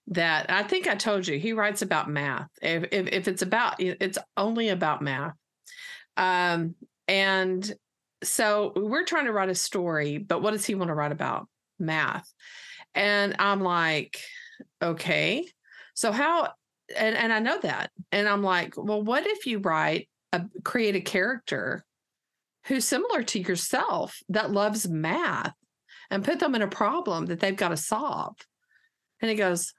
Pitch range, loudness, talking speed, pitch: 180-225 Hz, -27 LUFS, 165 wpm, 200 Hz